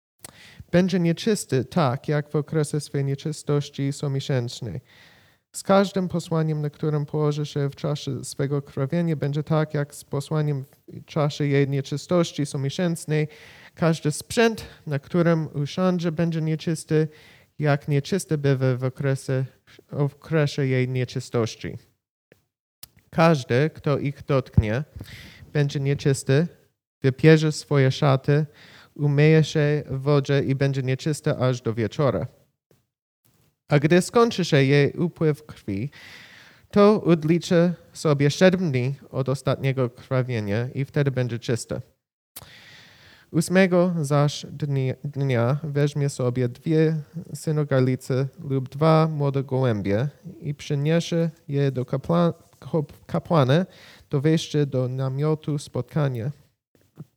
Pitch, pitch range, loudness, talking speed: 145 Hz, 135-160 Hz, -23 LUFS, 110 wpm